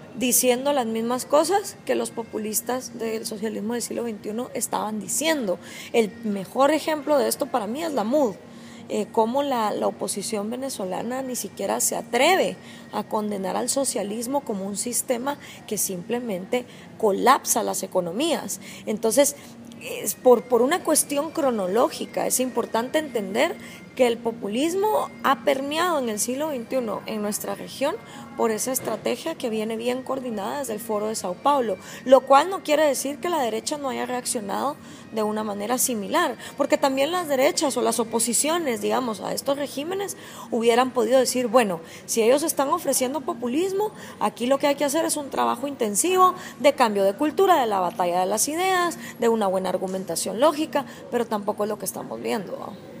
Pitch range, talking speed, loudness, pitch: 215-285 Hz, 170 wpm, -24 LUFS, 250 Hz